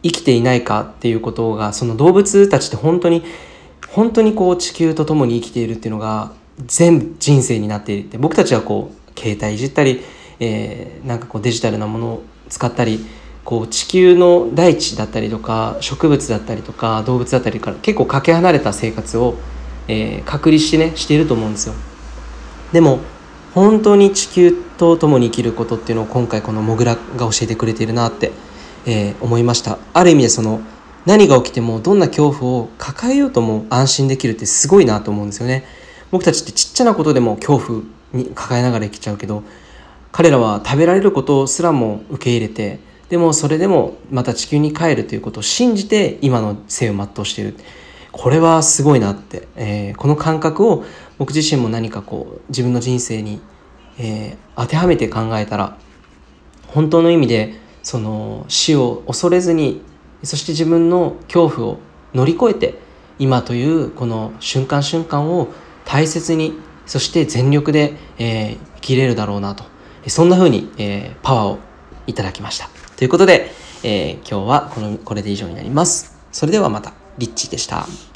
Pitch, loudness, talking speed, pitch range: 125 Hz, -15 LUFS, 365 characters per minute, 110-160 Hz